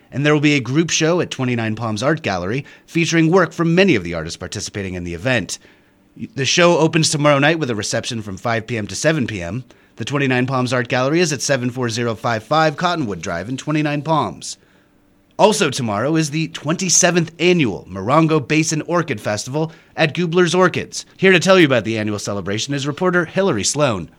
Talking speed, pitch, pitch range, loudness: 185 wpm, 145 Hz, 115-160 Hz, -17 LUFS